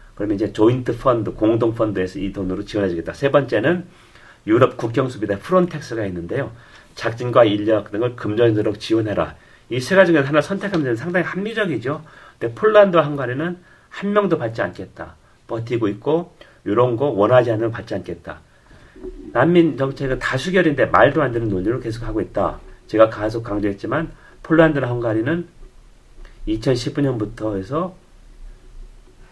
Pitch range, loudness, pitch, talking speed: 110-160 Hz, -19 LUFS, 125 Hz, 340 characters per minute